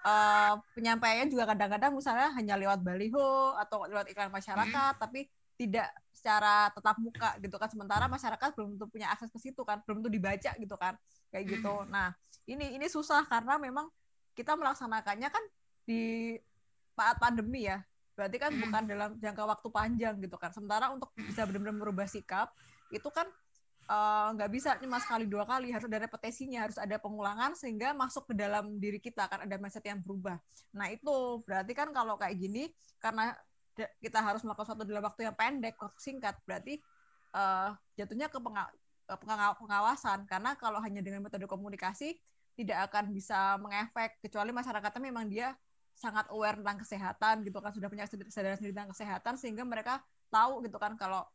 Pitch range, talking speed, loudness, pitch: 205-240 Hz, 170 wpm, -35 LUFS, 215 Hz